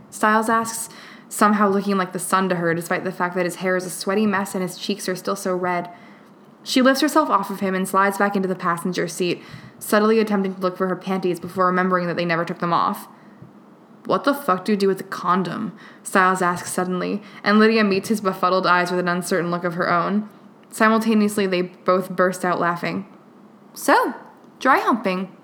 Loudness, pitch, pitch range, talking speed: -20 LUFS, 190 Hz, 180-210 Hz, 210 wpm